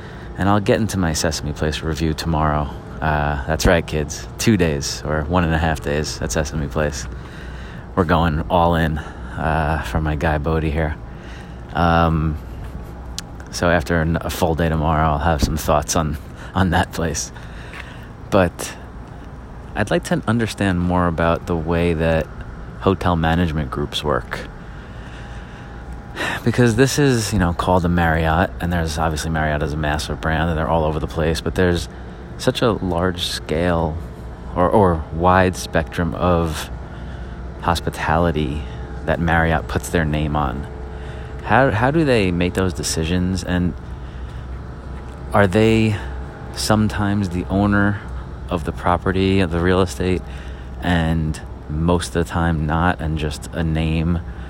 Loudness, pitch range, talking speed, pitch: -19 LUFS, 75-90 Hz, 145 wpm, 80 Hz